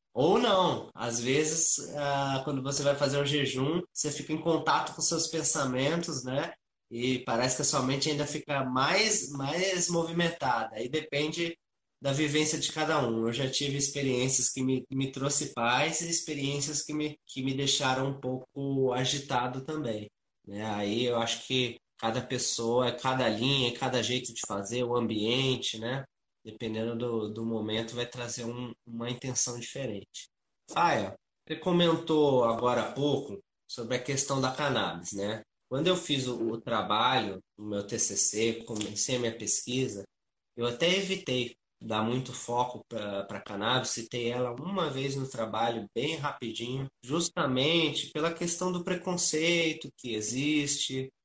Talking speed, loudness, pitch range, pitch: 150 wpm, -30 LUFS, 115-150 Hz, 130 Hz